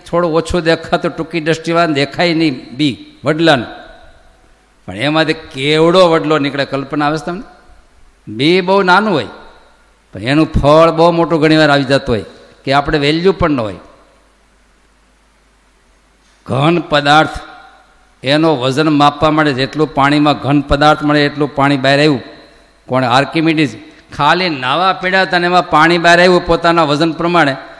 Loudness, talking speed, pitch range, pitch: -12 LUFS, 140 wpm, 145-170 Hz, 155 Hz